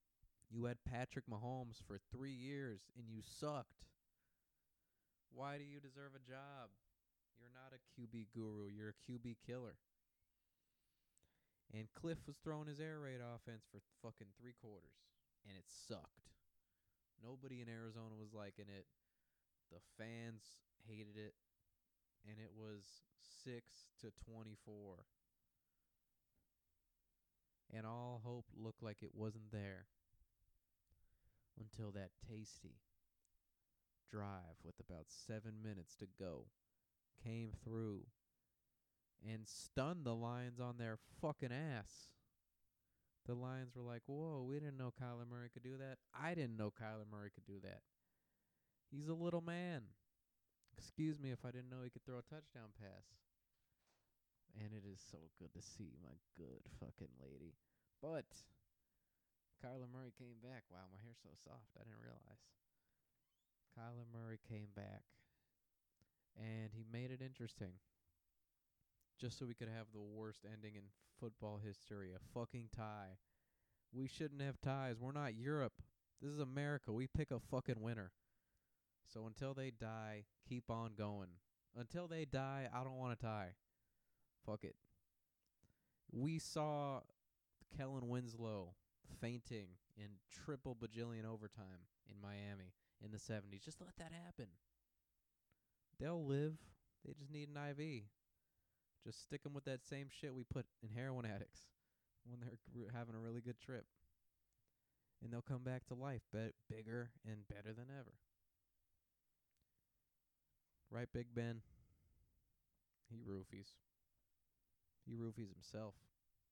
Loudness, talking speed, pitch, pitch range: -52 LUFS, 135 wpm, 115 Hz, 100-125 Hz